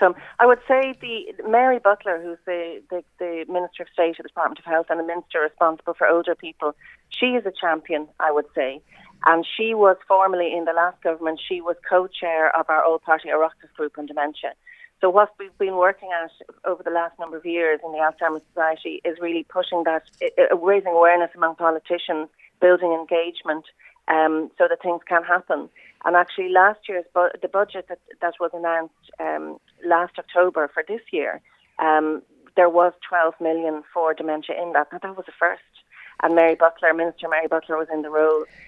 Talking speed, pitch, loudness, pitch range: 190 wpm, 170 Hz, -21 LUFS, 160-180 Hz